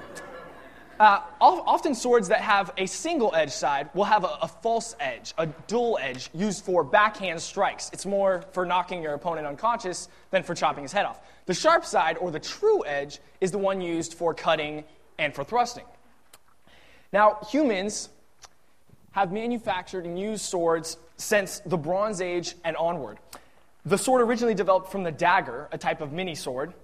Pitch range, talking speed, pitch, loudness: 165-215 Hz, 170 wpm, 185 Hz, -26 LUFS